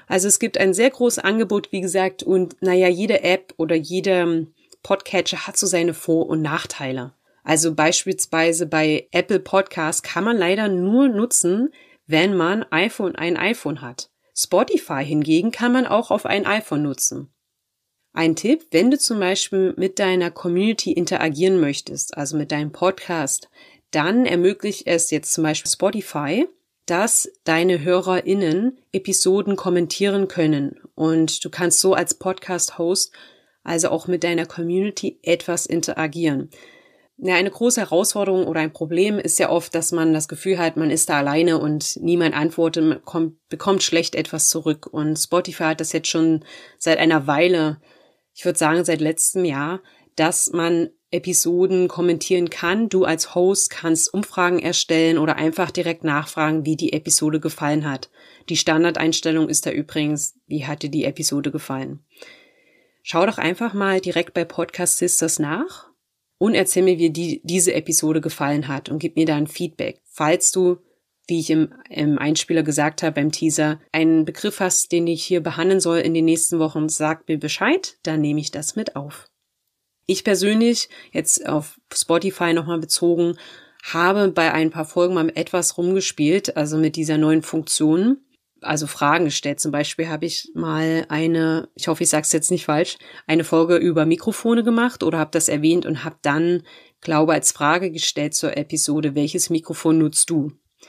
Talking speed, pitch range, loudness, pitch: 165 wpm, 155-185 Hz, -20 LUFS, 165 Hz